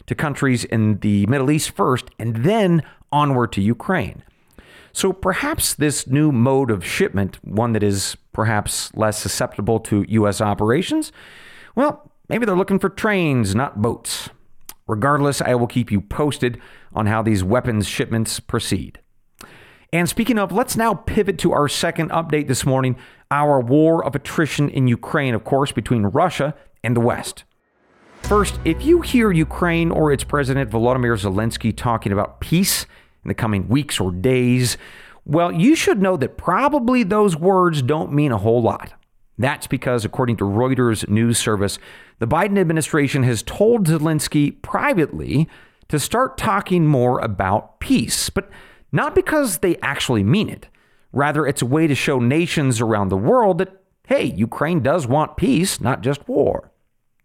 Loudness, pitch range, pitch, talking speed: -19 LUFS, 115-165 Hz, 135 Hz, 160 wpm